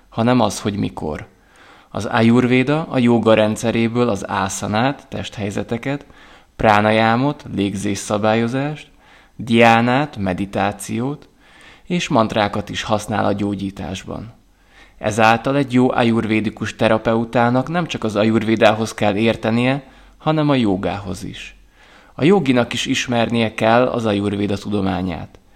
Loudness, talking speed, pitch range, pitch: -18 LUFS, 105 wpm, 100-125 Hz, 115 Hz